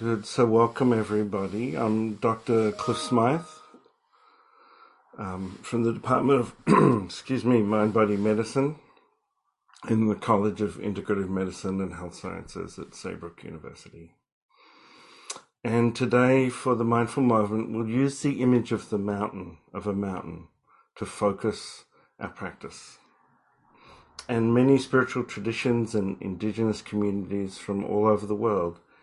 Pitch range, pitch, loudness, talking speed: 105-120 Hz, 110 Hz, -26 LUFS, 125 wpm